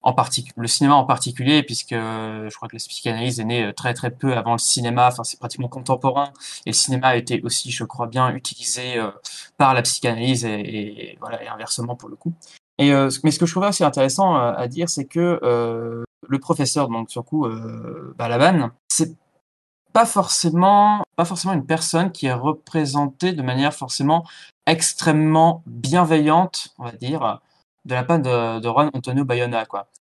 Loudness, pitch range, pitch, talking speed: -20 LUFS, 120-155 Hz, 130 Hz, 180 wpm